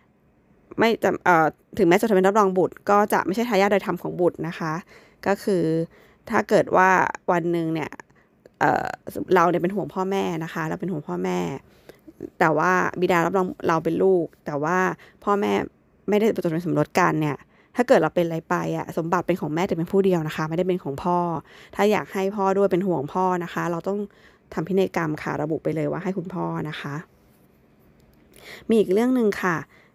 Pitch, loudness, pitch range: 180 Hz, -23 LUFS, 165-195 Hz